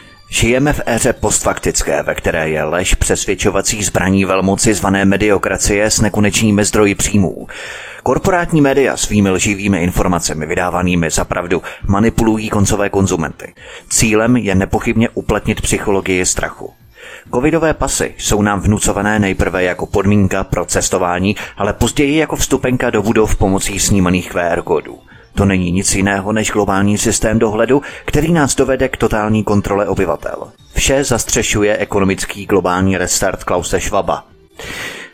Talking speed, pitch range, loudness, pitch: 130 wpm, 95-115 Hz, -14 LUFS, 105 Hz